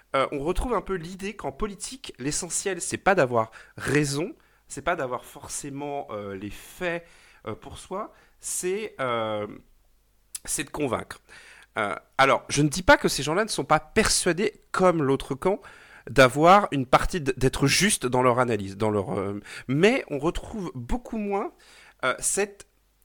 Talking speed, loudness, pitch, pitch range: 160 wpm, -25 LUFS, 155 Hz, 125-195 Hz